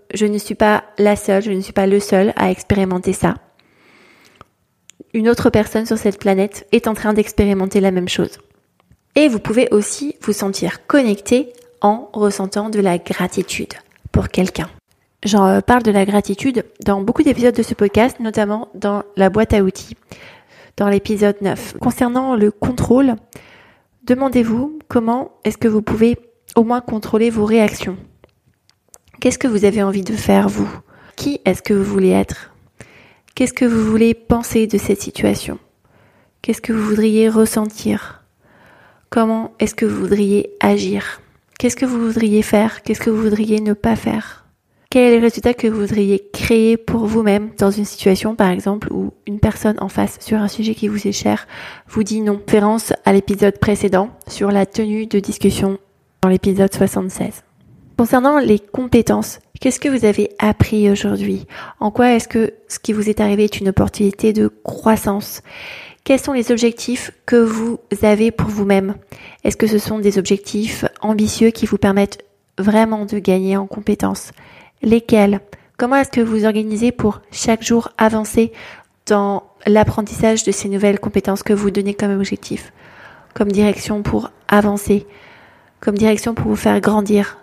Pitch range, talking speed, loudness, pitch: 200-225 Hz, 165 wpm, -16 LUFS, 210 Hz